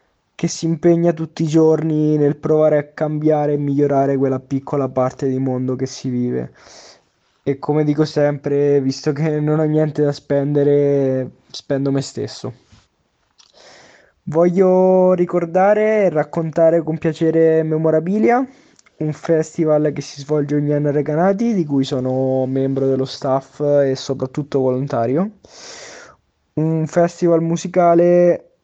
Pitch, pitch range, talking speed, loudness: 150 Hz, 135-165 Hz, 130 wpm, -17 LUFS